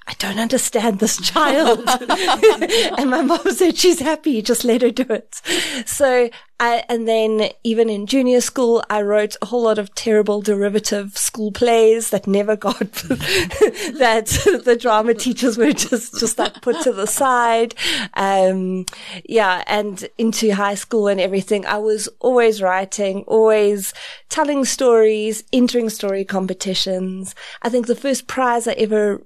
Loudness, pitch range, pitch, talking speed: -17 LUFS, 210-250 Hz, 230 Hz, 150 wpm